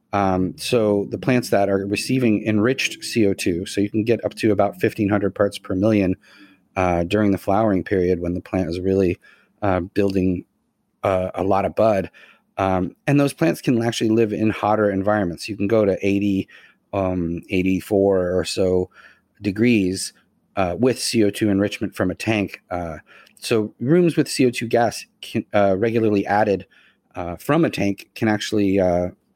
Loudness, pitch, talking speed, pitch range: -21 LUFS, 100 Hz, 165 wpm, 95-110 Hz